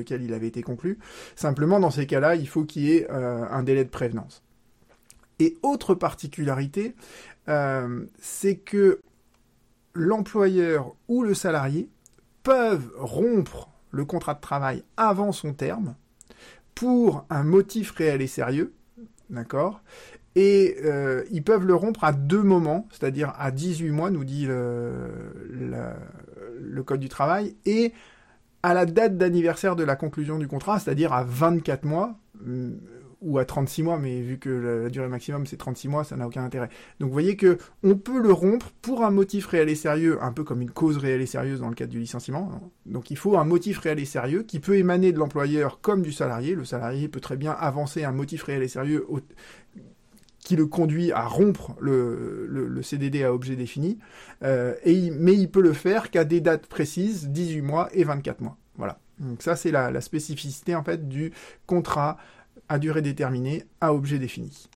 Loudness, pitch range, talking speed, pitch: -25 LUFS, 135-185 Hz, 190 wpm, 155 Hz